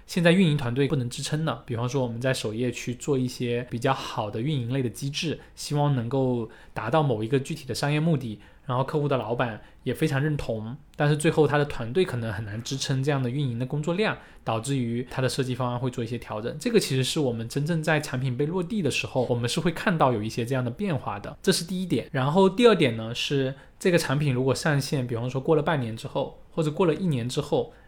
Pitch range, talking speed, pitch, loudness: 120-155 Hz, 365 characters per minute, 135 Hz, -26 LUFS